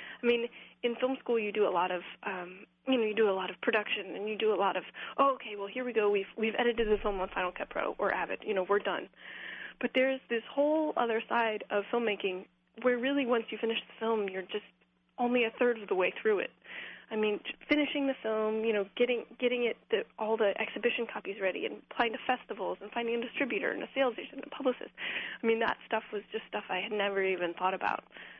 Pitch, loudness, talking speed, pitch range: 225 Hz, -32 LUFS, 245 wpm, 205-245 Hz